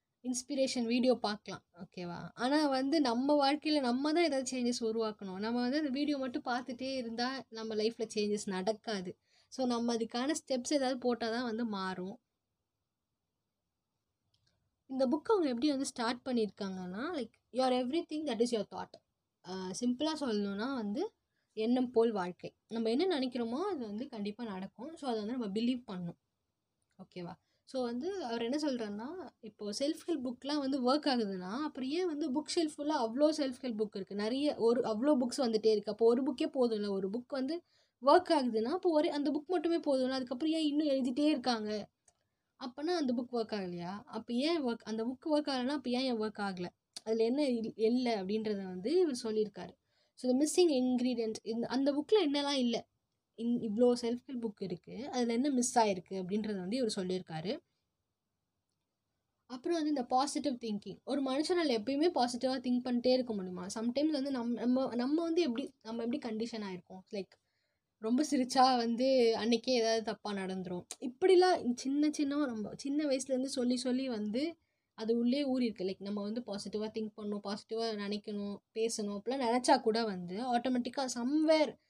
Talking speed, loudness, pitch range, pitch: 165 wpm, -34 LUFS, 220-275 Hz, 245 Hz